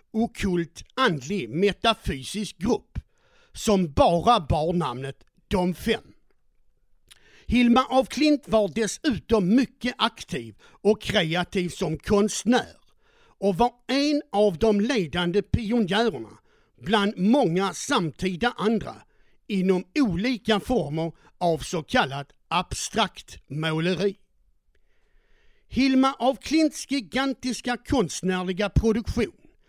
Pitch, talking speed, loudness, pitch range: 215 Hz, 95 wpm, -24 LUFS, 185-250 Hz